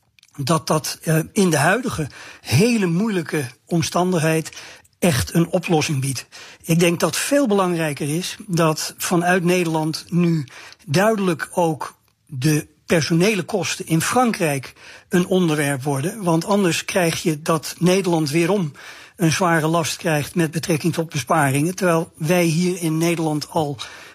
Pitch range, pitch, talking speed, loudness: 155-180 Hz, 165 Hz, 130 wpm, -20 LUFS